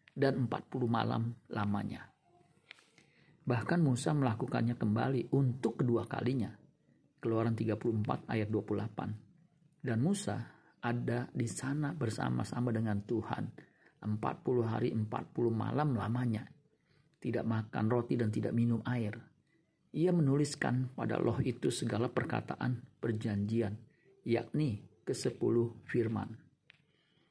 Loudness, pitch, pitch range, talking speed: -35 LUFS, 120 Hz, 110-135 Hz, 100 wpm